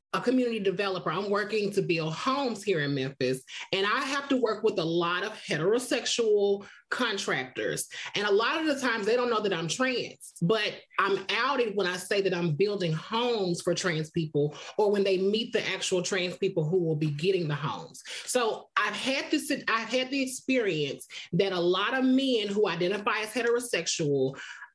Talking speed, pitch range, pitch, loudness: 190 wpm, 175-235 Hz, 200 Hz, -28 LUFS